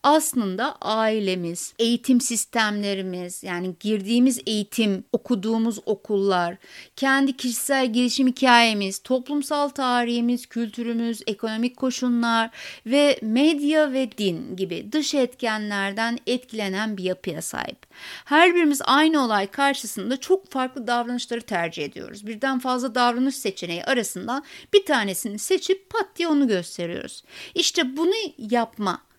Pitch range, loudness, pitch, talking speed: 210-270 Hz, -23 LUFS, 240 Hz, 110 wpm